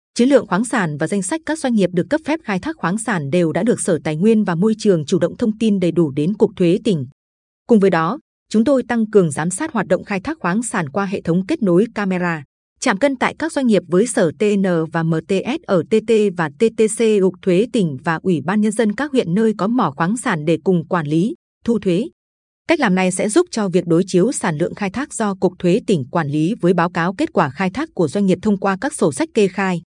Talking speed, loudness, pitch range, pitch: 260 wpm, -18 LUFS, 175-225 Hz, 195 Hz